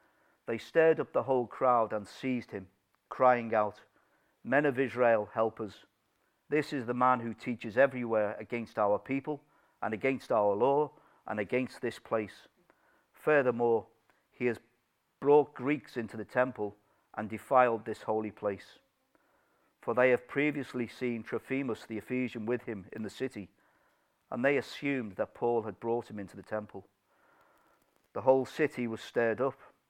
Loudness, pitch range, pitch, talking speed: -31 LUFS, 110-130 Hz, 120 Hz, 155 wpm